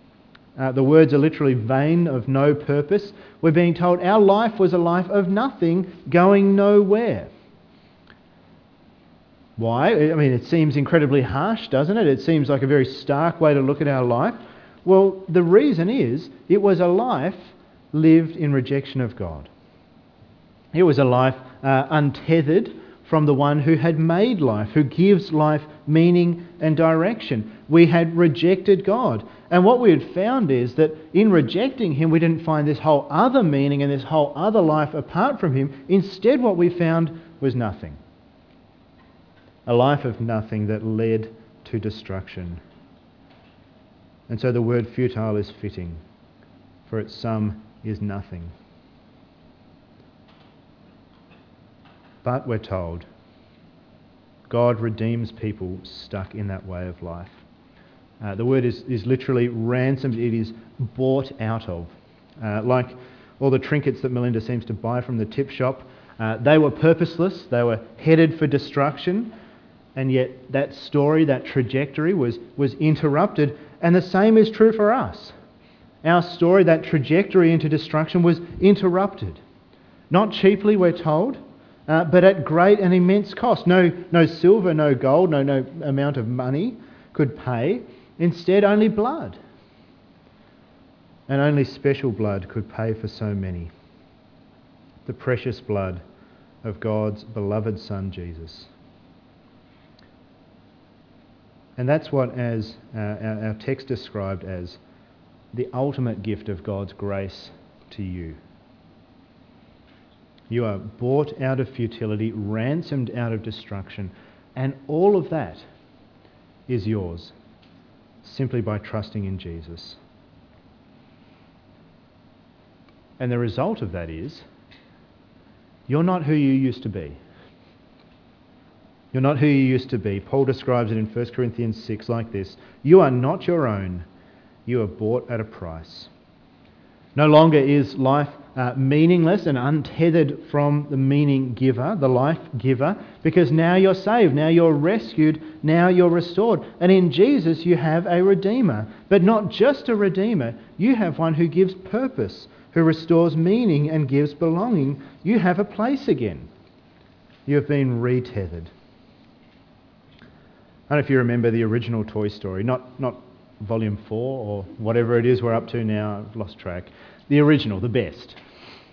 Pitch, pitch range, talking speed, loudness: 135 Hz, 110-165 Hz, 145 wpm, -20 LUFS